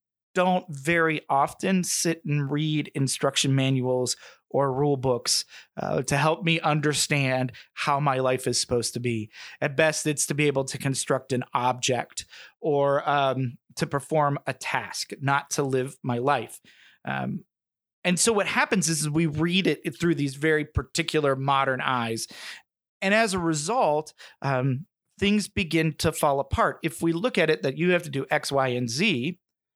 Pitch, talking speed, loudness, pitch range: 145 Hz, 165 wpm, -25 LUFS, 135-165 Hz